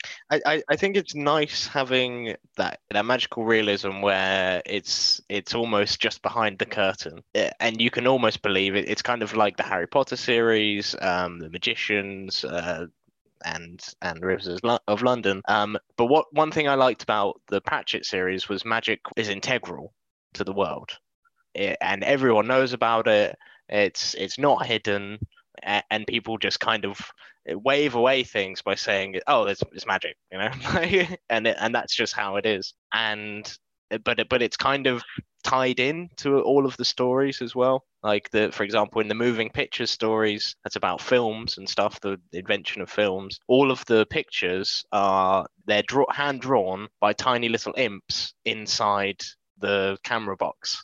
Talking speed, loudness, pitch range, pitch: 170 wpm, -24 LUFS, 100-130 Hz, 115 Hz